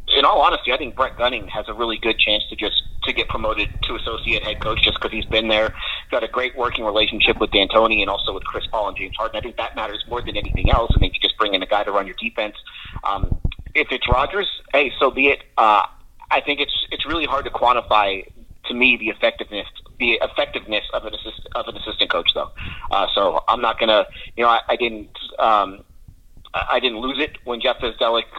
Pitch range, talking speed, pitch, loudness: 105-120 Hz, 235 wpm, 110 Hz, -19 LUFS